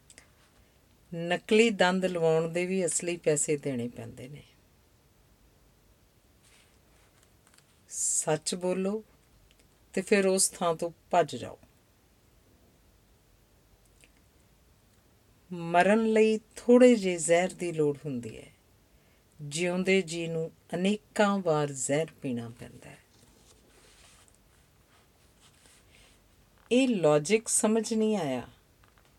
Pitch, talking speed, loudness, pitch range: 160 Hz, 85 wpm, -27 LUFS, 115-185 Hz